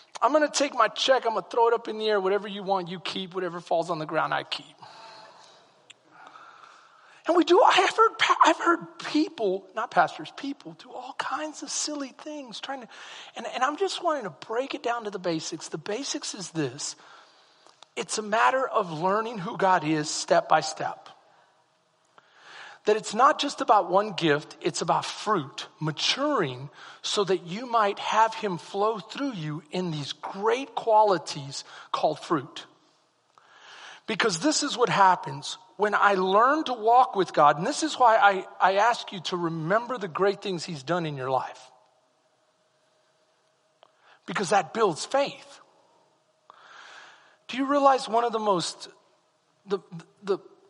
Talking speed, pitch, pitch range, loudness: 170 wpm, 205 Hz, 175-260 Hz, -25 LUFS